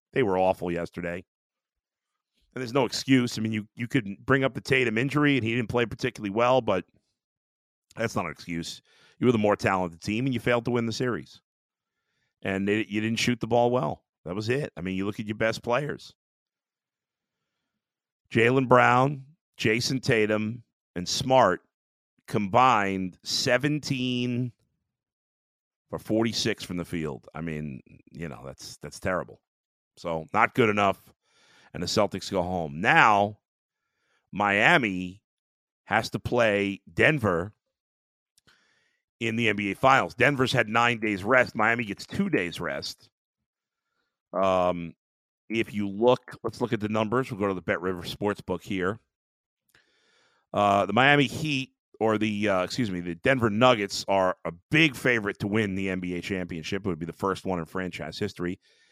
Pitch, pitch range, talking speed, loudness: 110 Hz, 95-125 Hz, 160 wpm, -26 LUFS